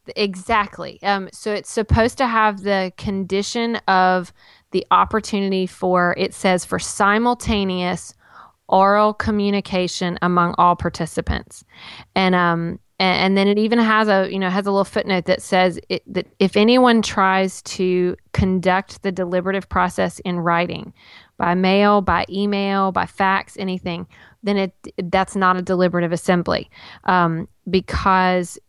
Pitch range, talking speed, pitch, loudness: 180-200 Hz, 140 wpm, 190 Hz, -19 LUFS